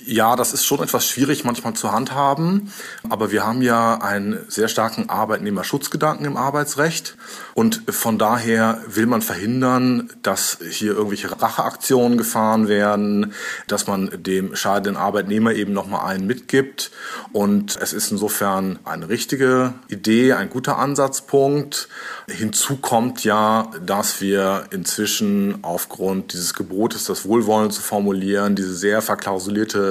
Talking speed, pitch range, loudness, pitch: 130 wpm, 100-130 Hz, -20 LUFS, 110 Hz